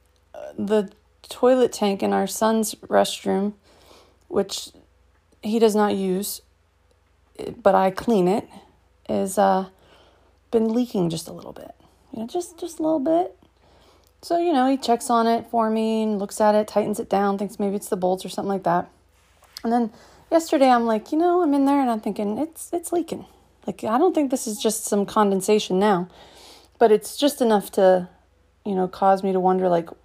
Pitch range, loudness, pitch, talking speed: 190-240 Hz, -22 LUFS, 210 Hz, 190 wpm